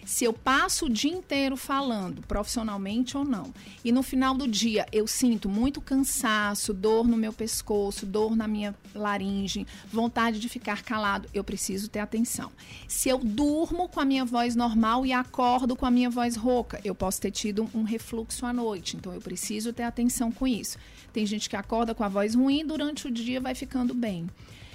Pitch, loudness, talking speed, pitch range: 230 Hz, -28 LUFS, 195 wpm, 210-255 Hz